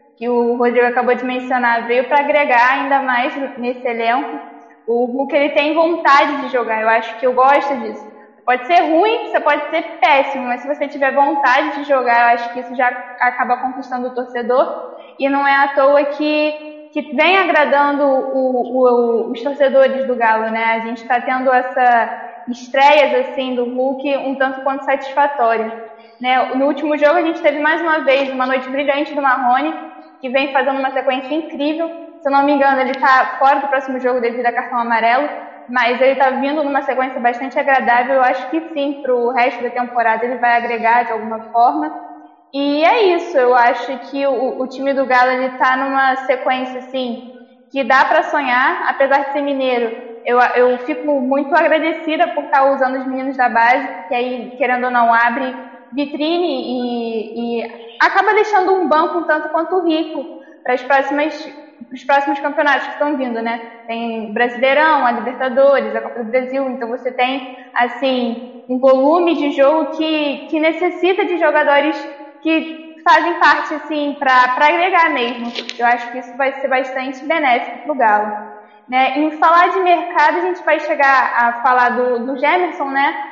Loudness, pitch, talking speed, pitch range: -15 LUFS, 265 Hz, 185 wpm, 245-290 Hz